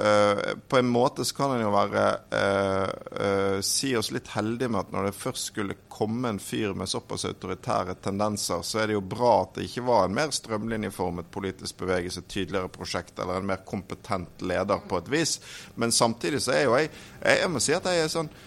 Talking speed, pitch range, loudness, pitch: 220 wpm, 95-115 Hz, -27 LUFS, 105 Hz